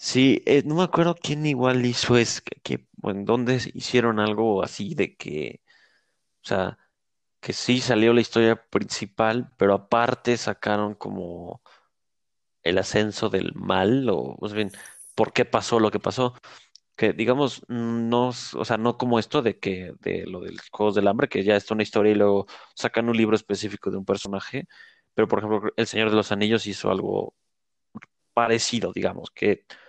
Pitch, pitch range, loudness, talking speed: 115 Hz, 105-125 Hz, -24 LUFS, 180 wpm